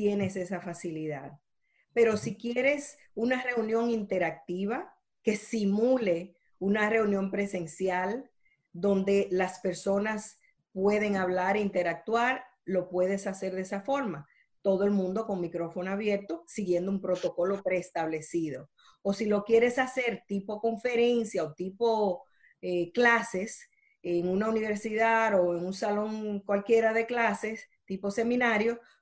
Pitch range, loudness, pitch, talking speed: 180-225 Hz, -29 LUFS, 200 Hz, 125 wpm